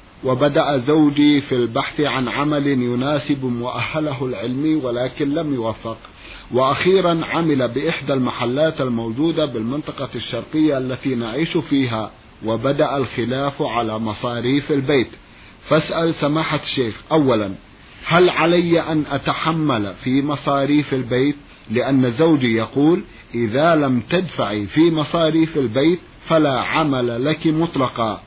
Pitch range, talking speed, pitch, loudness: 120-155 Hz, 110 wpm, 140 Hz, -19 LUFS